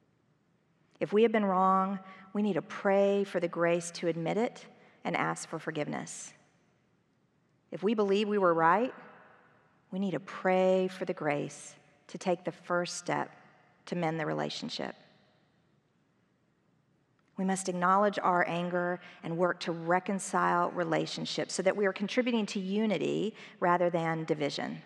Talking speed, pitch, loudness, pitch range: 145 wpm, 180 Hz, -31 LUFS, 165-195 Hz